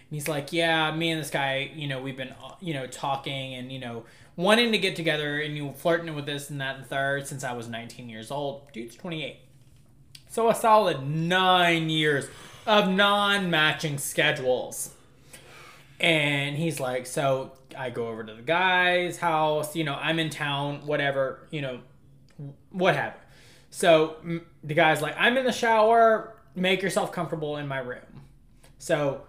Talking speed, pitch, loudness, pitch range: 170 wpm, 150 Hz, -25 LUFS, 135-170 Hz